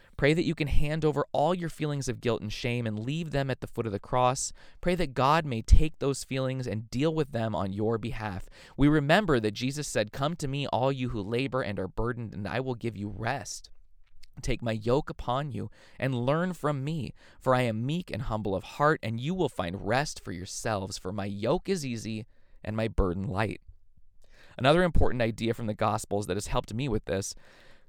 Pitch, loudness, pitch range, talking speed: 115 Hz, -30 LUFS, 105-140 Hz, 220 wpm